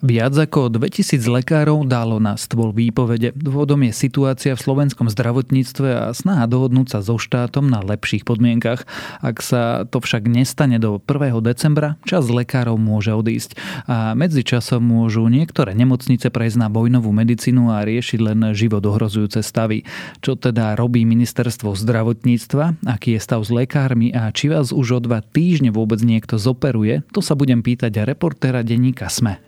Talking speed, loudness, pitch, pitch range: 160 wpm, -17 LUFS, 120 Hz, 115-135 Hz